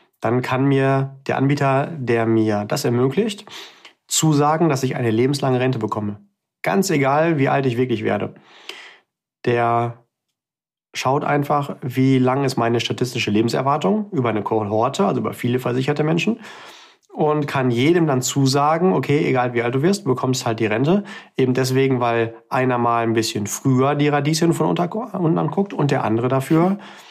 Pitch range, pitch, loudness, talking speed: 120-150 Hz, 130 Hz, -19 LUFS, 160 wpm